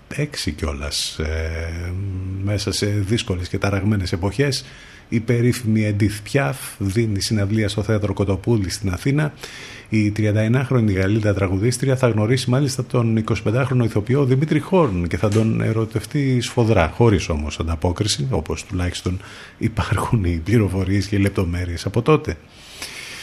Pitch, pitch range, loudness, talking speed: 105 Hz, 95-120 Hz, -20 LUFS, 125 wpm